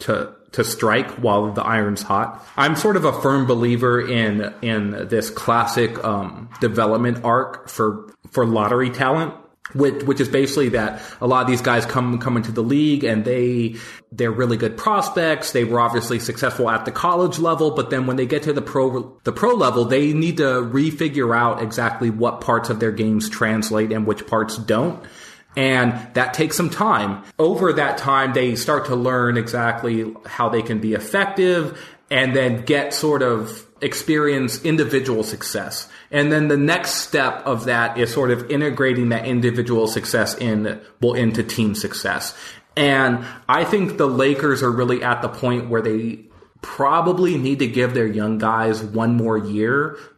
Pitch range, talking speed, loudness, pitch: 115-140 Hz, 175 wpm, -19 LUFS, 125 Hz